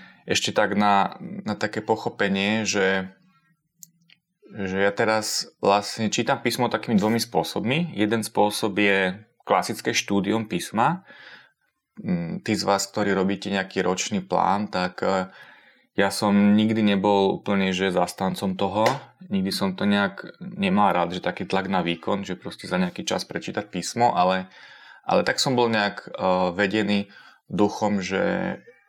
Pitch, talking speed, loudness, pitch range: 105 Hz, 135 wpm, -23 LUFS, 95-115 Hz